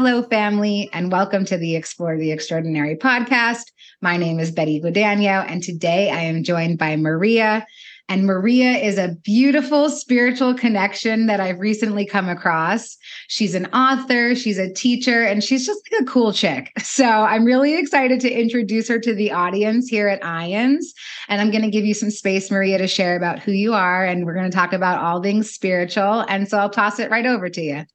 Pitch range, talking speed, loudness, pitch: 180-235 Hz, 200 wpm, -18 LUFS, 205 Hz